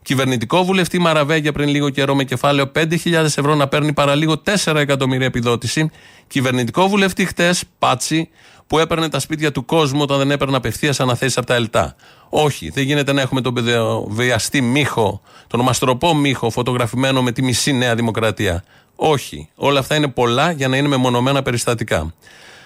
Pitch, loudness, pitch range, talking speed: 140 Hz, -17 LUFS, 125-150 Hz, 160 wpm